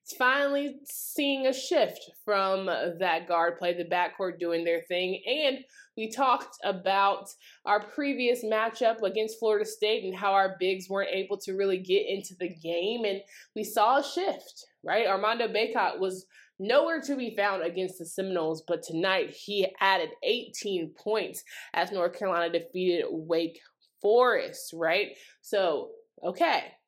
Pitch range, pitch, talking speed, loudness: 185-260 Hz, 200 Hz, 145 wpm, -28 LUFS